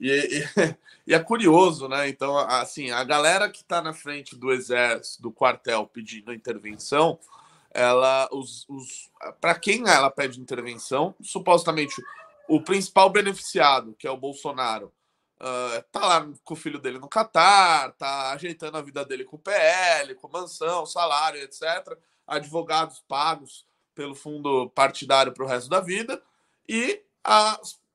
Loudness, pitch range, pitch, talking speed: -23 LUFS, 135-185 Hz, 150 Hz, 145 wpm